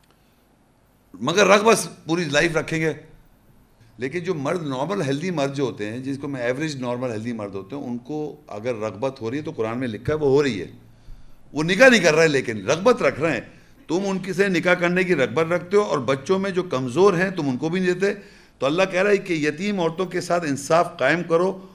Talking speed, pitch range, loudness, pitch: 235 wpm, 130-185 Hz, -21 LUFS, 160 Hz